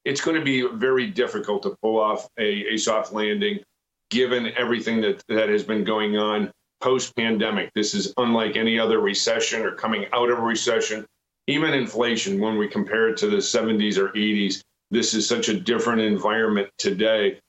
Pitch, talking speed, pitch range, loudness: 110 Hz, 180 wpm, 105-120 Hz, -23 LUFS